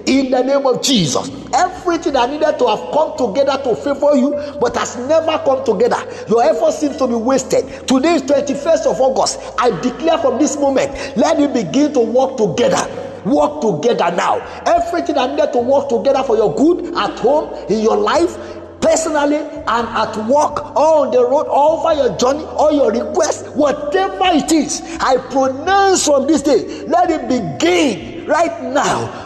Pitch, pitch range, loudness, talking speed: 290 Hz, 265-325 Hz, -15 LUFS, 180 wpm